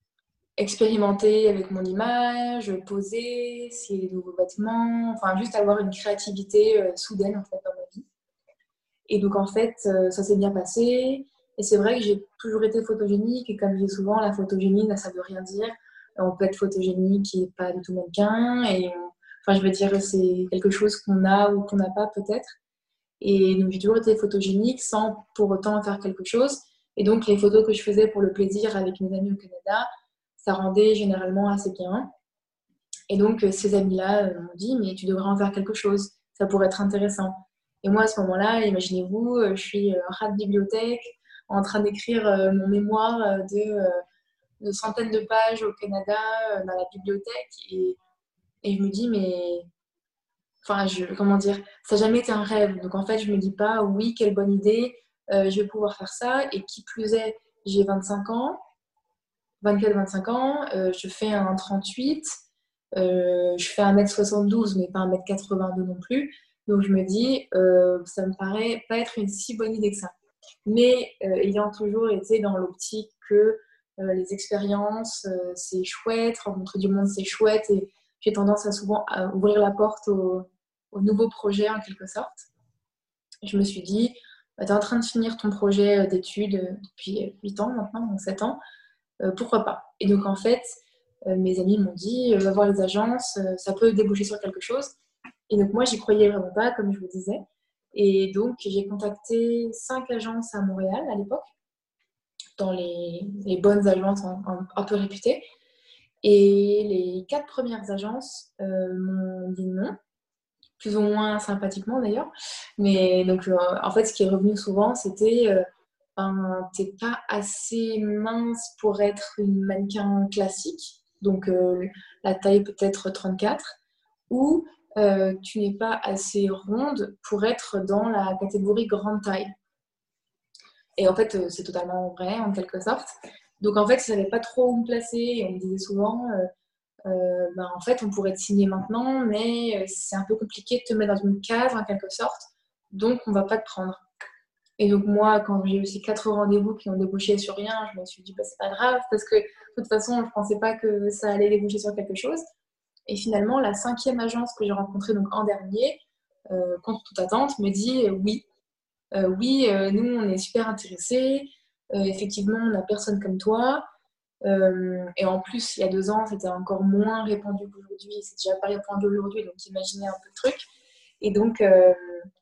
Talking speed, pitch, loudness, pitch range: 190 wpm, 205 Hz, -24 LUFS, 195-225 Hz